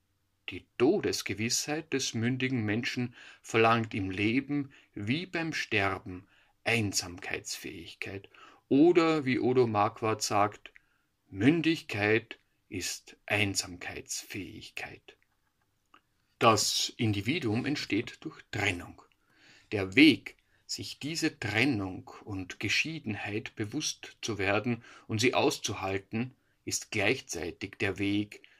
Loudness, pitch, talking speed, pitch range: -30 LUFS, 115 Hz, 90 wpm, 100-135 Hz